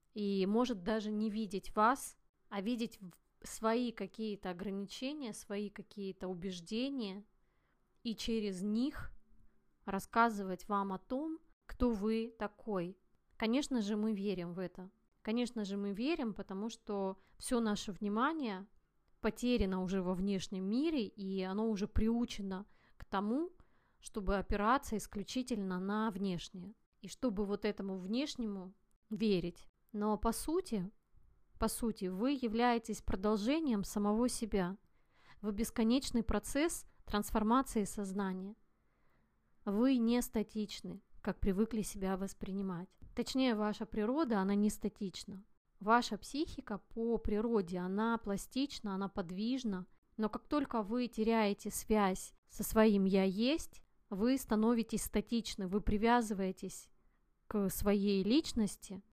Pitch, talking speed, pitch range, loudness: 215 Hz, 115 wpm, 195-230 Hz, -37 LUFS